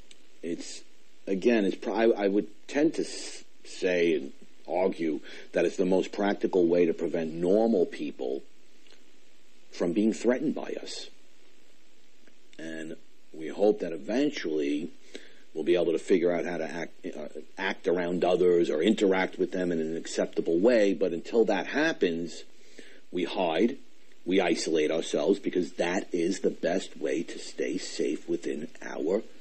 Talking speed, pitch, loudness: 145 wpm, 90 Hz, -28 LUFS